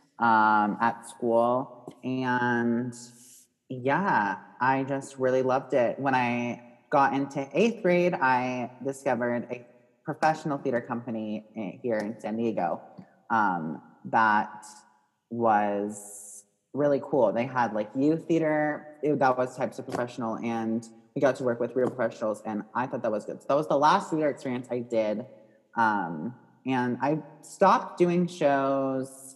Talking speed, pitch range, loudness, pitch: 145 wpm, 115-140 Hz, -27 LUFS, 125 Hz